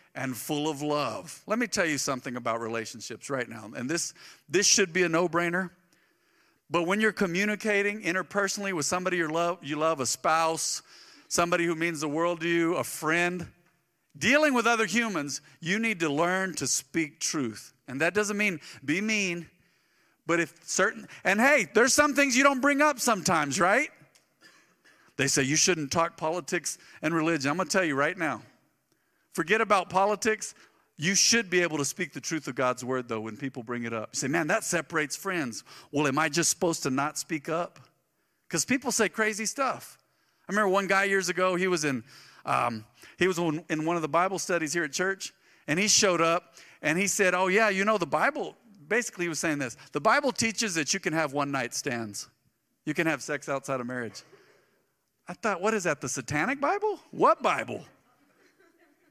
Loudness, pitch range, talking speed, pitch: -27 LUFS, 150-205 Hz, 195 wpm, 175 Hz